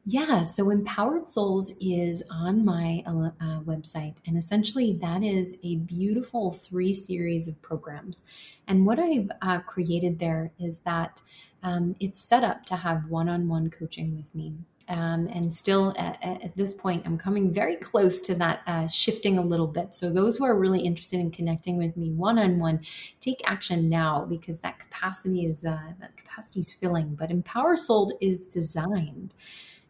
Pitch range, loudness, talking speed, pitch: 165-195 Hz, -26 LUFS, 175 wpm, 175 Hz